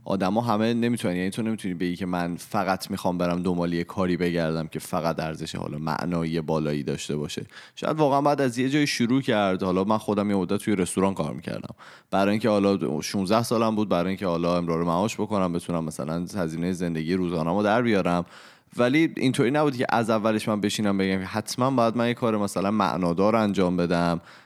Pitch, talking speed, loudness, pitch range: 95 Hz, 195 wpm, -25 LUFS, 85-110 Hz